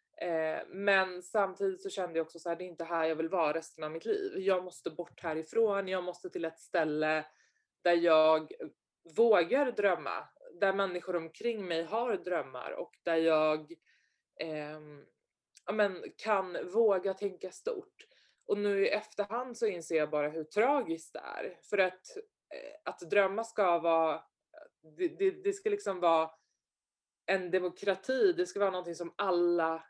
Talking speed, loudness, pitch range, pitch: 160 wpm, -32 LUFS, 165-210 Hz, 185 Hz